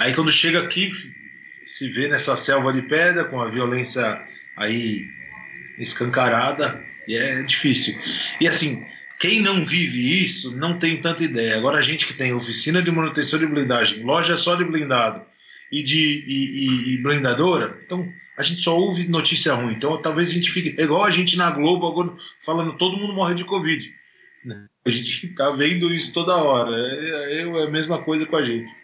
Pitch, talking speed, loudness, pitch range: 155 Hz, 180 wpm, -20 LUFS, 125-170 Hz